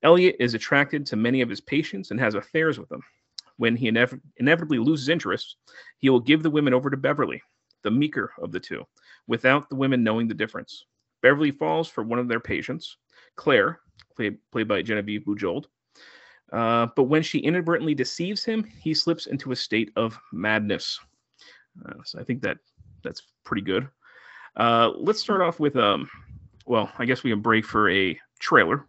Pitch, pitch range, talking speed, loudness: 125 Hz, 115-155 Hz, 185 wpm, -24 LUFS